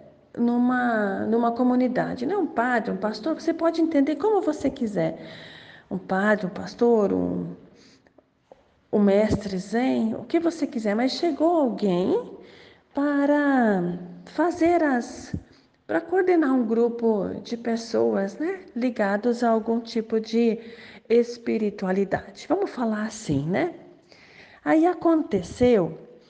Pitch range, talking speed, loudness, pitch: 210-295 Hz, 115 wpm, -24 LUFS, 235 Hz